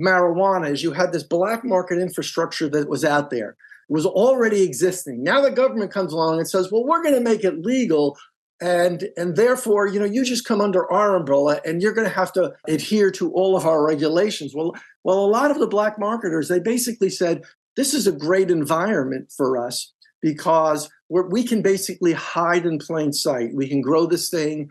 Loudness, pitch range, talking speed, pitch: -20 LUFS, 160-205 Hz, 205 wpm, 180 Hz